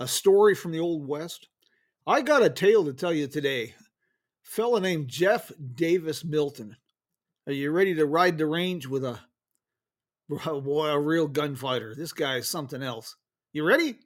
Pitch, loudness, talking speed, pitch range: 160 Hz, -26 LUFS, 170 wpm, 145-190 Hz